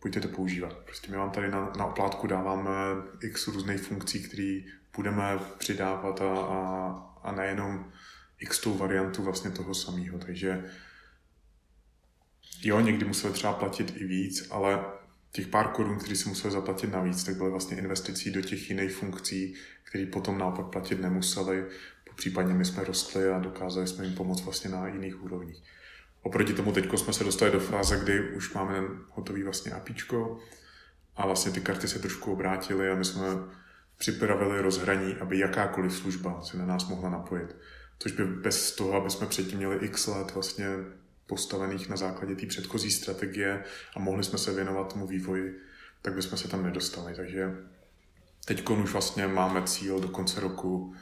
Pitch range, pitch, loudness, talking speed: 95-100 Hz, 95 Hz, -31 LUFS, 165 wpm